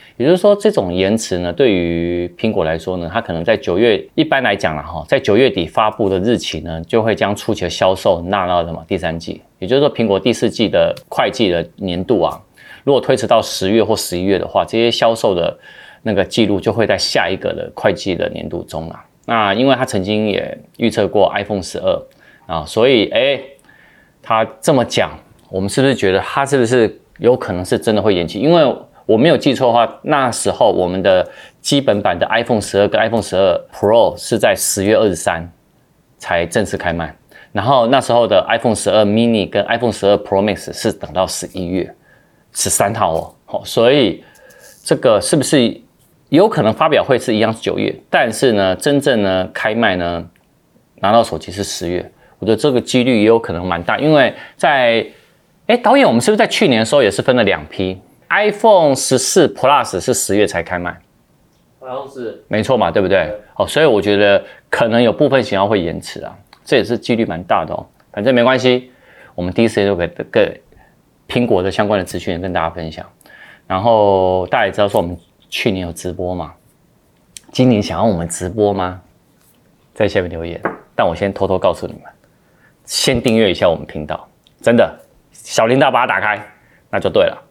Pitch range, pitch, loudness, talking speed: 90-115 Hz, 100 Hz, -15 LUFS, 315 characters per minute